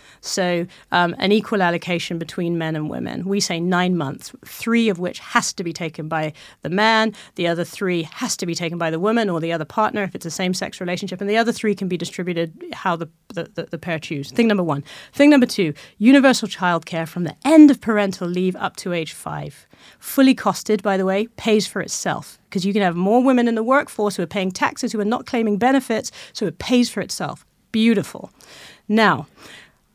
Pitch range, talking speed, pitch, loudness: 170-220 Hz, 215 wpm, 190 Hz, -20 LUFS